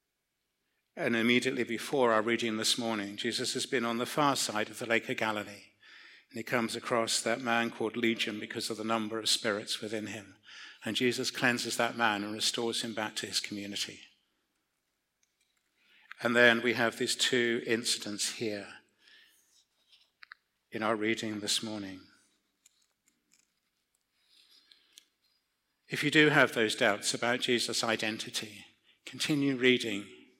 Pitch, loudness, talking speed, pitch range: 115 Hz, -30 LUFS, 140 wpm, 110-120 Hz